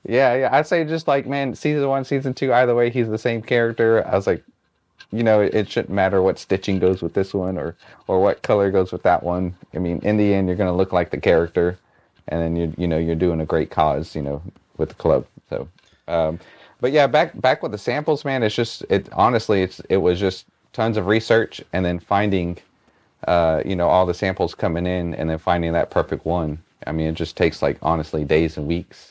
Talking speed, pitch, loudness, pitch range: 235 wpm, 95 Hz, -20 LUFS, 85-110 Hz